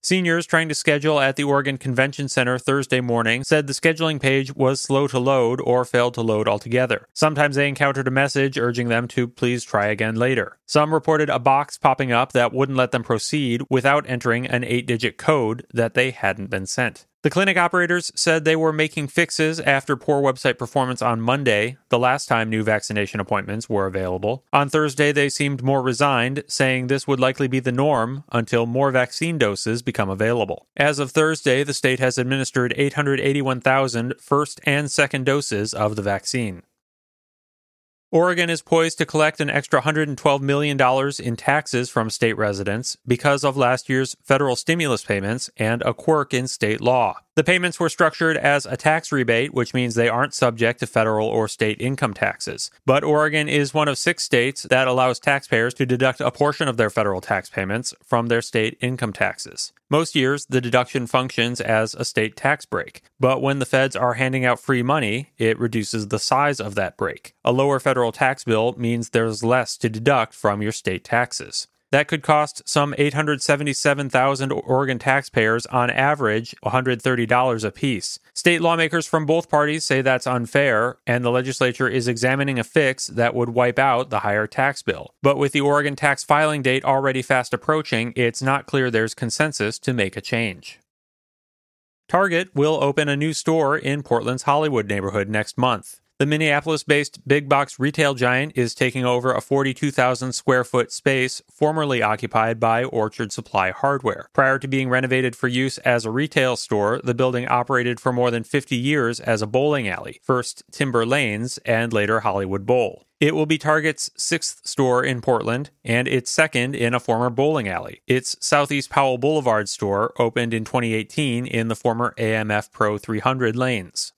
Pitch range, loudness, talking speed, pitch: 120-145 Hz, -20 LUFS, 180 wpm, 130 Hz